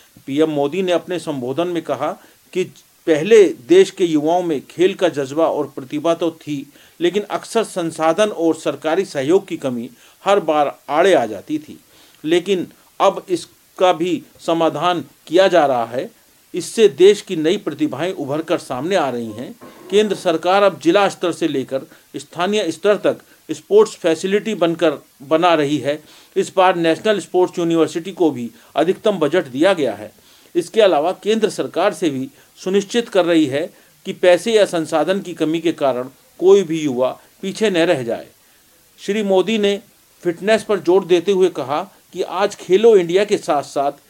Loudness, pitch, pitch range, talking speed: -17 LUFS, 175 Hz, 155-200 Hz, 165 wpm